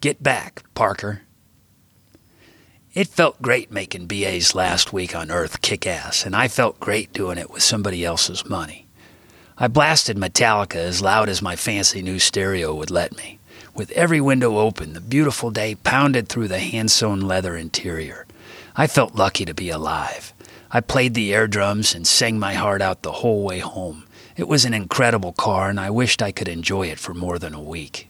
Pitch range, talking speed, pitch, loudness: 90-115 Hz, 190 wpm, 100 Hz, -20 LUFS